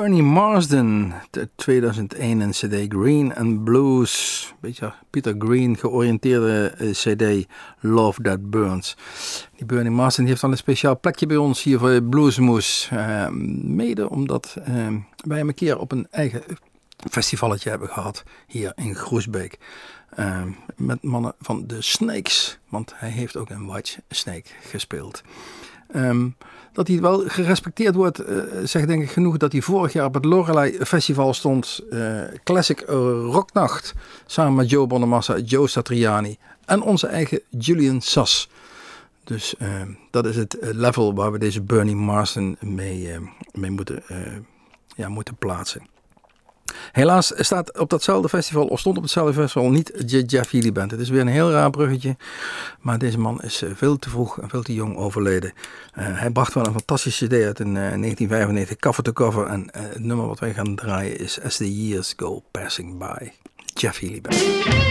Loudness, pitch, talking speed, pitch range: -21 LUFS, 120 Hz, 165 wpm, 105-145 Hz